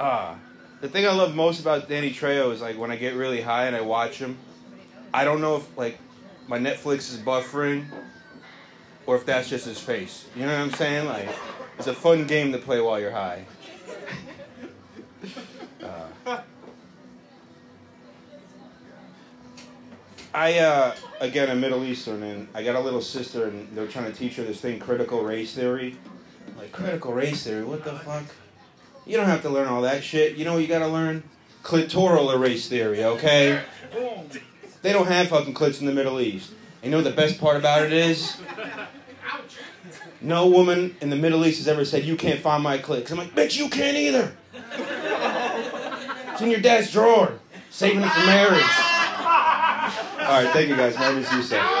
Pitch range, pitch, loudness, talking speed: 125-165 Hz, 150 Hz, -23 LUFS, 180 wpm